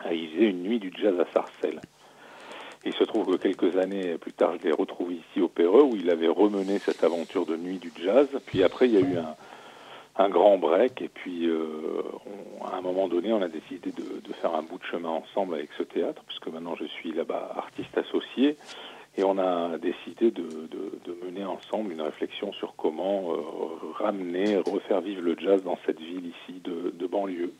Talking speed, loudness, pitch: 210 wpm, -27 LUFS, 100 Hz